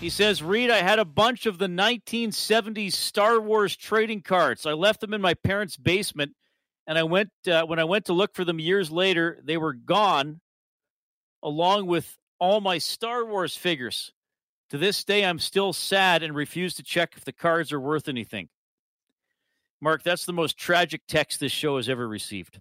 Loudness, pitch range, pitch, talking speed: -24 LUFS, 155-205 Hz, 175 Hz, 190 wpm